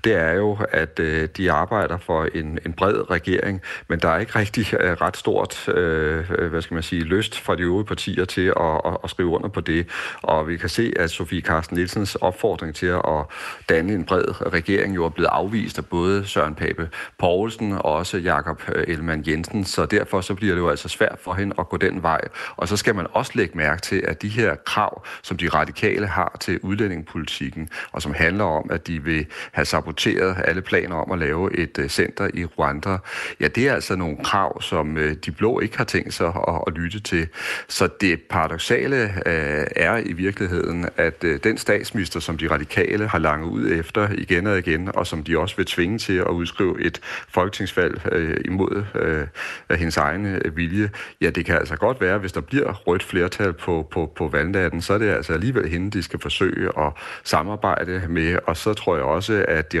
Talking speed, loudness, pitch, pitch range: 200 wpm, -22 LUFS, 85 Hz, 80-100 Hz